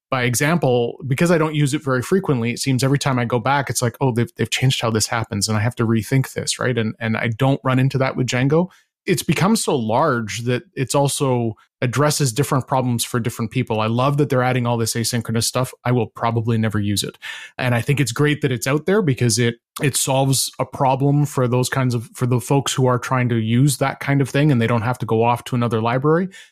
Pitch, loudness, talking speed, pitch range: 125 Hz, -19 LUFS, 250 wpm, 120-140 Hz